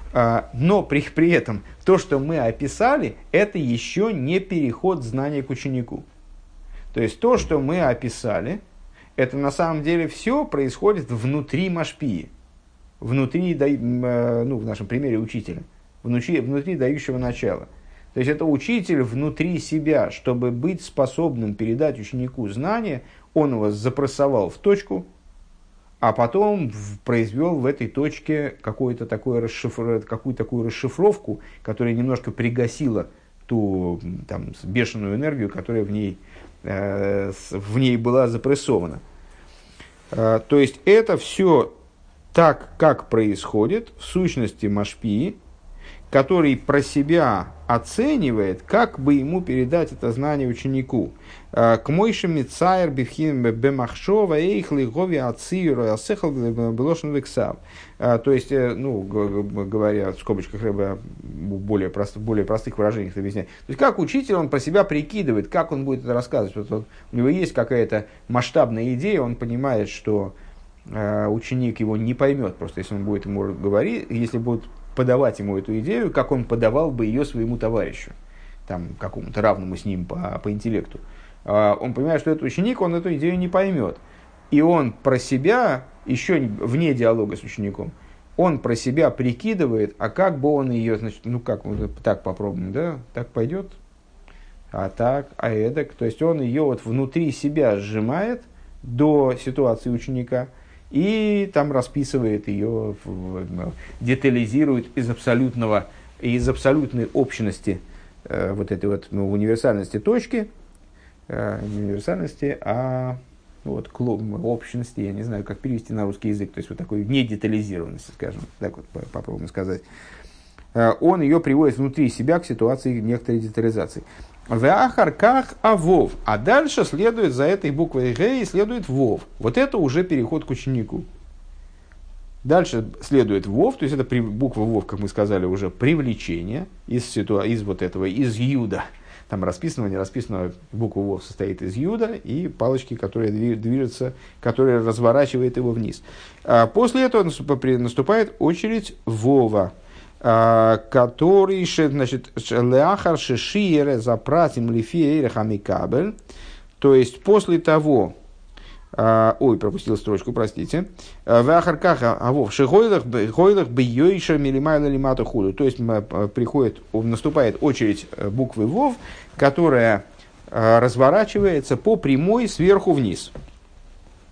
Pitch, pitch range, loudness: 120 Hz, 105-145 Hz, -21 LUFS